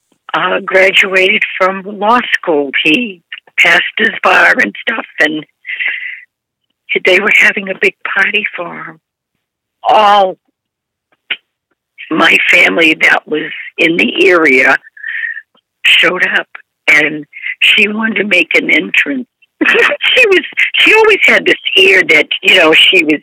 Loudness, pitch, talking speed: -8 LUFS, 210 Hz, 125 wpm